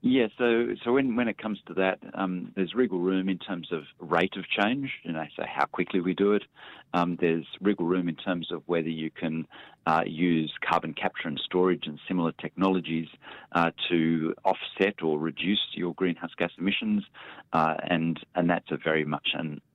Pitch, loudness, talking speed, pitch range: 85 Hz, -28 LUFS, 190 wpm, 80-95 Hz